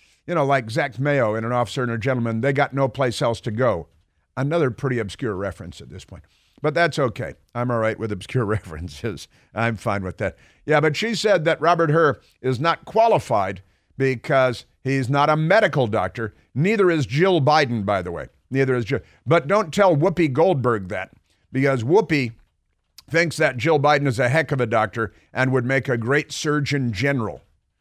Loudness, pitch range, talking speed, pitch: -21 LUFS, 115-150 Hz, 190 wpm, 130 Hz